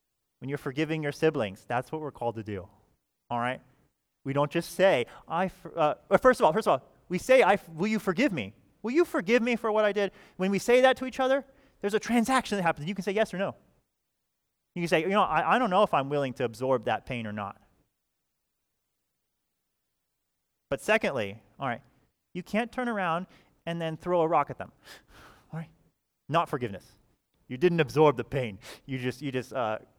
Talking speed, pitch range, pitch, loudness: 210 wpm, 135-210 Hz, 165 Hz, -28 LUFS